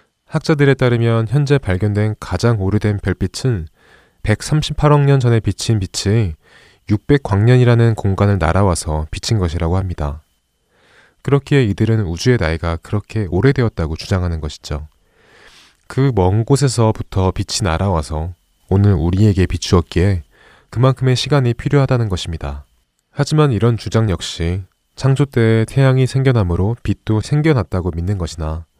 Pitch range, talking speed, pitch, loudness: 90-125 Hz, 315 characters per minute, 105 Hz, -16 LUFS